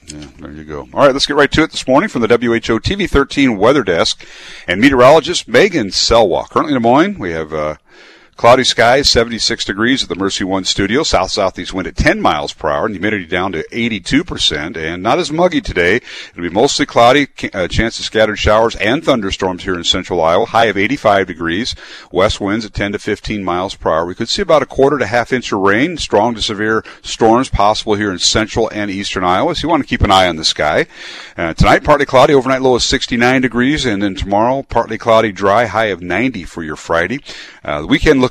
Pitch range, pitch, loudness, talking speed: 95-125 Hz, 110 Hz, -13 LUFS, 220 wpm